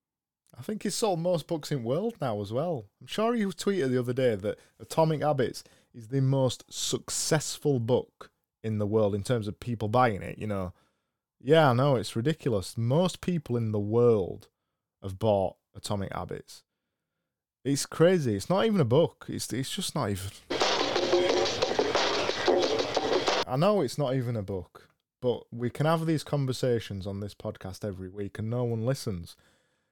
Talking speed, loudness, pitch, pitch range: 175 wpm, -28 LUFS, 125 Hz, 105-150 Hz